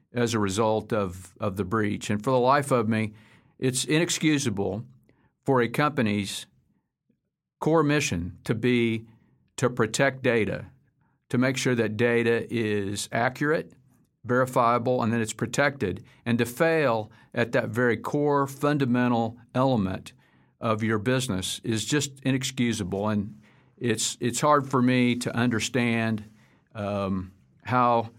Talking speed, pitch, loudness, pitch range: 130 wpm, 120 Hz, -26 LUFS, 110-130 Hz